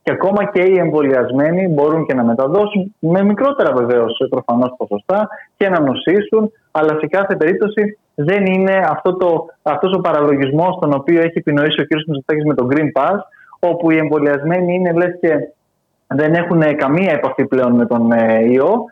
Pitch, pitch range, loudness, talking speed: 160 Hz, 140-185 Hz, -15 LUFS, 165 wpm